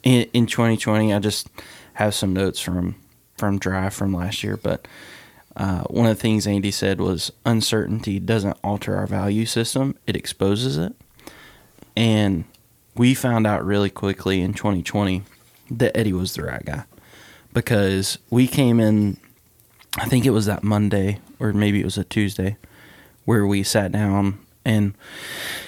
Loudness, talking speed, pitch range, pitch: -21 LUFS, 155 wpm, 100-115 Hz, 105 Hz